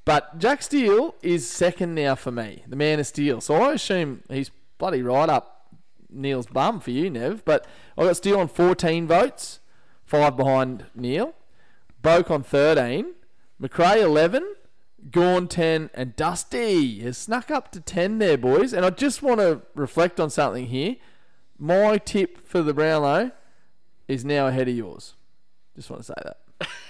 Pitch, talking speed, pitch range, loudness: 160 Hz, 160 wpm, 135-185 Hz, -22 LUFS